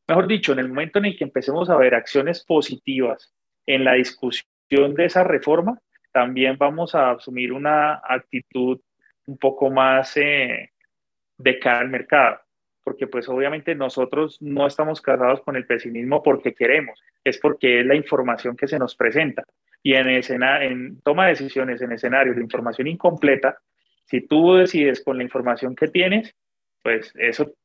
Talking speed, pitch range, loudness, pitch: 165 wpm, 125-150 Hz, -20 LUFS, 135 Hz